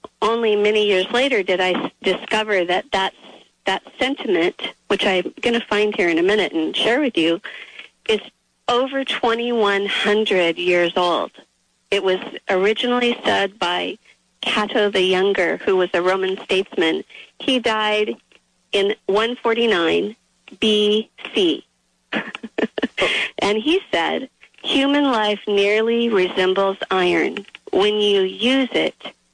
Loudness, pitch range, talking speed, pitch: -19 LUFS, 190-240 Hz, 120 wpm, 210 Hz